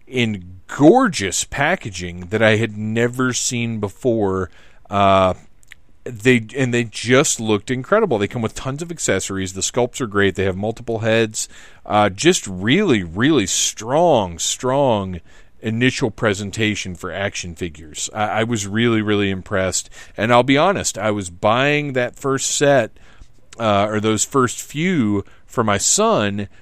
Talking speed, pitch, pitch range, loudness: 145 wpm, 110 Hz, 95-125 Hz, -18 LUFS